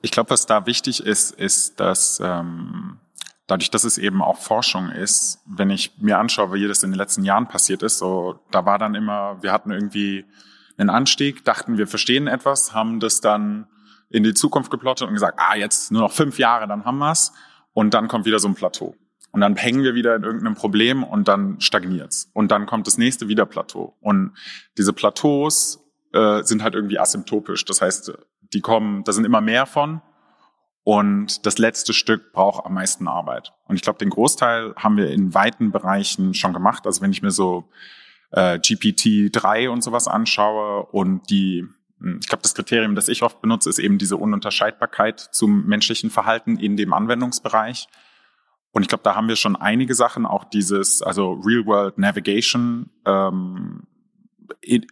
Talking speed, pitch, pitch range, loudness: 185 wpm, 110 Hz, 100-130 Hz, -19 LUFS